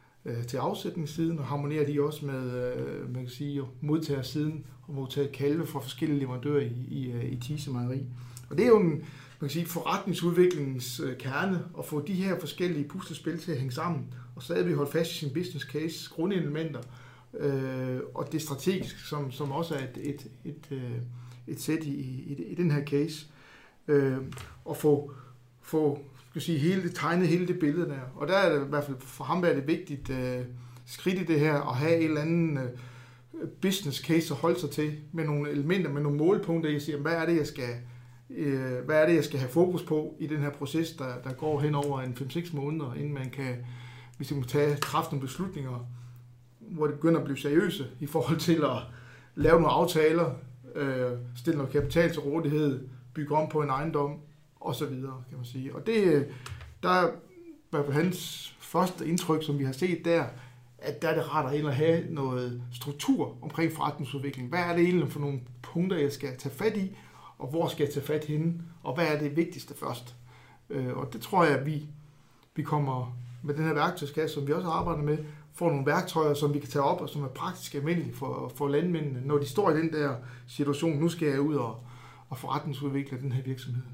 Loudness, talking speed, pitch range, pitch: -30 LUFS, 205 wpm, 130-160 Hz, 145 Hz